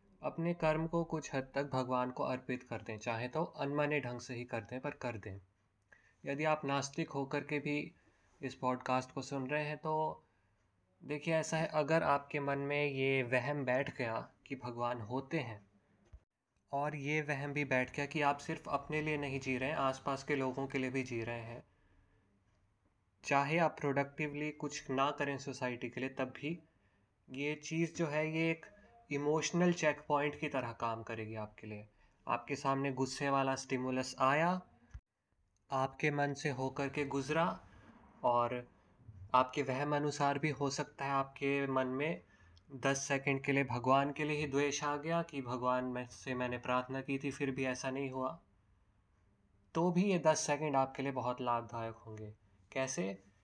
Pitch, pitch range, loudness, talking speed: 135 Hz, 120-145 Hz, -37 LUFS, 175 wpm